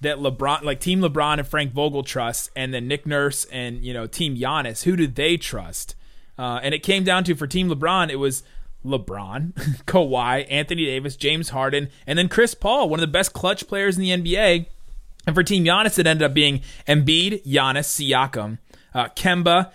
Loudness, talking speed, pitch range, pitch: -21 LUFS, 195 wpm, 130-175 Hz, 145 Hz